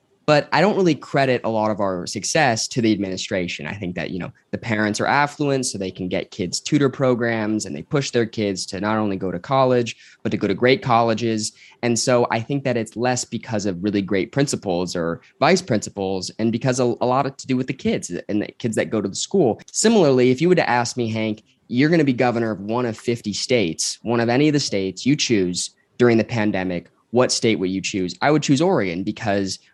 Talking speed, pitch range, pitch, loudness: 240 wpm, 100-130 Hz, 115 Hz, -21 LUFS